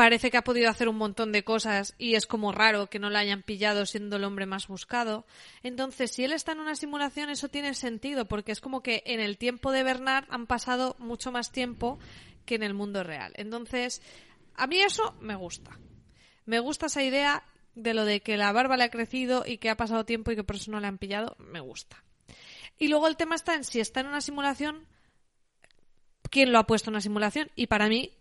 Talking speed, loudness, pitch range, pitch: 230 wpm, -28 LUFS, 215-265 Hz, 235 Hz